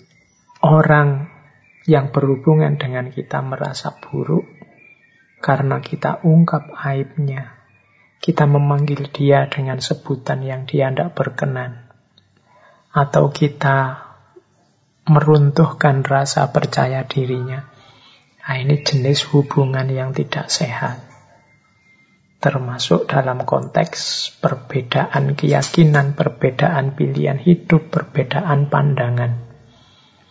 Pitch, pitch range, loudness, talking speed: 140 Hz, 130-150 Hz, -17 LUFS, 85 wpm